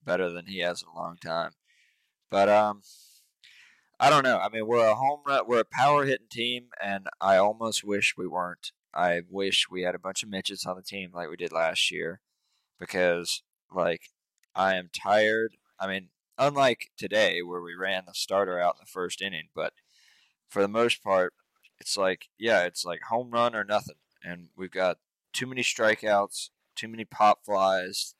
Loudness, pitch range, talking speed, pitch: -27 LUFS, 90-110 Hz, 190 wpm, 100 Hz